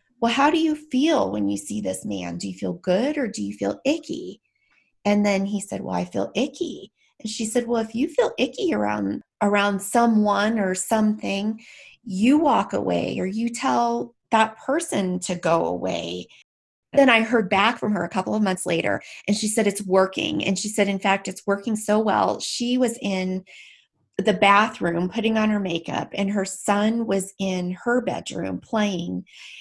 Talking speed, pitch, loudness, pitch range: 190 wpm, 205 Hz, -23 LUFS, 185-230 Hz